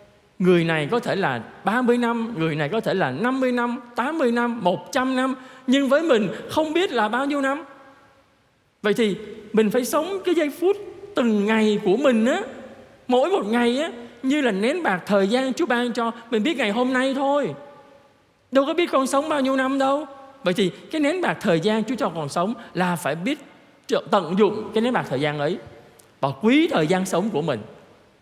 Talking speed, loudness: 205 wpm, -22 LUFS